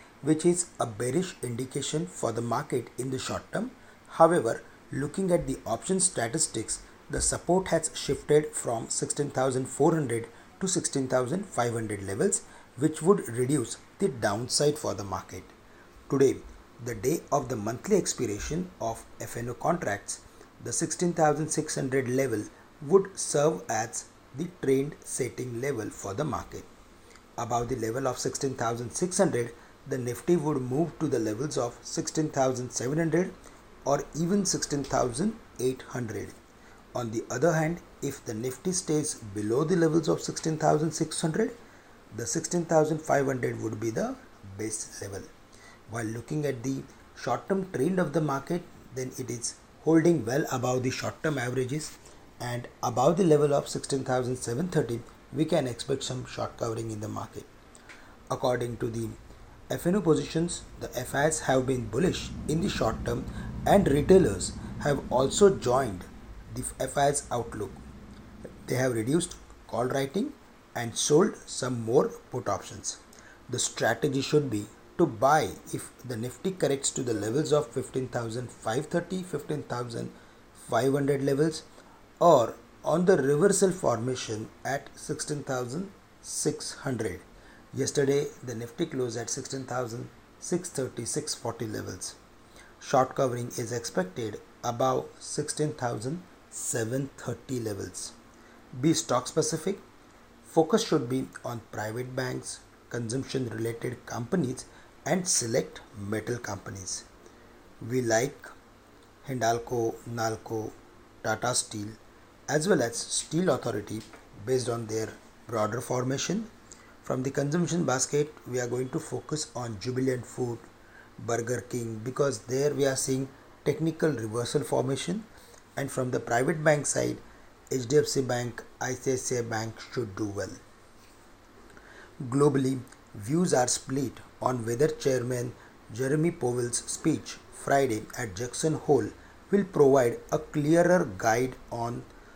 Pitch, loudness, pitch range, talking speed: 130 Hz, -29 LUFS, 115-155 Hz, 120 wpm